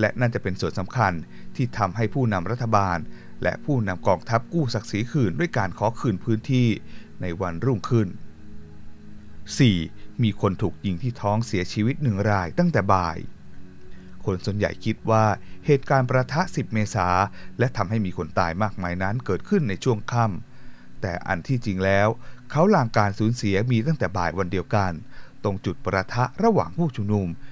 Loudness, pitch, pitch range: -24 LUFS, 105 Hz, 95-120 Hz